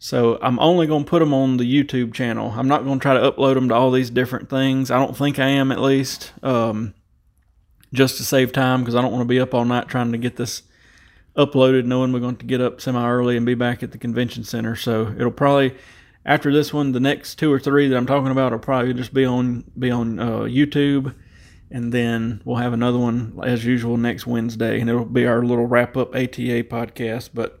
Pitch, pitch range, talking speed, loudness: 125 Hz, 120-135 Hz, 235 wpm, -20 LUFS